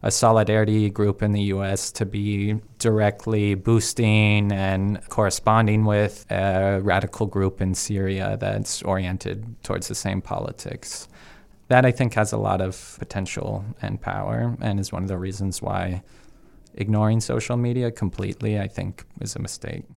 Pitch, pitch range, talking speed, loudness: 105 Hz, 95-110 Hz, 150 wpm, -23 LUFS